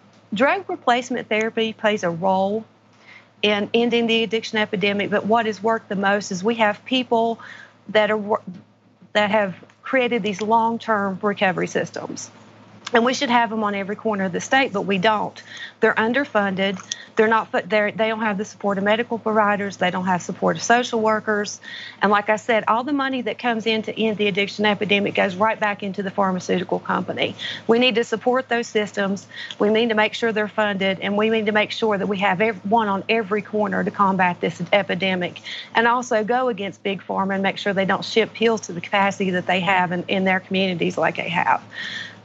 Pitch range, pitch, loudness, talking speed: 200-225 Hz, 215 Hz, -21 LUFS, 205 wpm